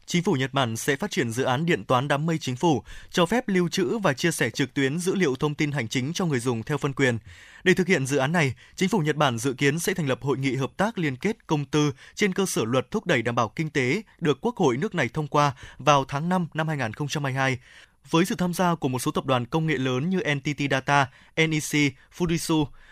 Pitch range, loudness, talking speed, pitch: 135-175 Hz, -25 LUFS, 255 wpm, 150 Hz